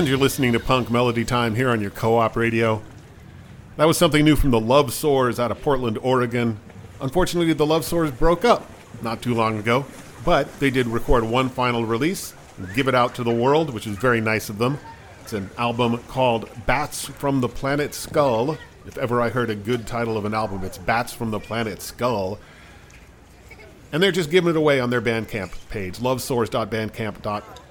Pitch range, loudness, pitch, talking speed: 110-135 Hz, -22 LUFS, 120 Hz, 195 wpm